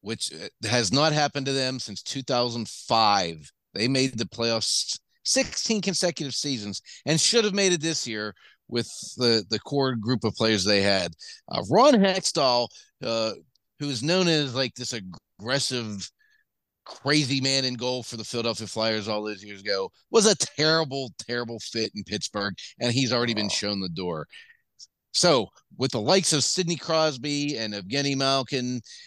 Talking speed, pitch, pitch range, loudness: 160 wpm, 125 Hz, 110-150 Hz, -25 LUFS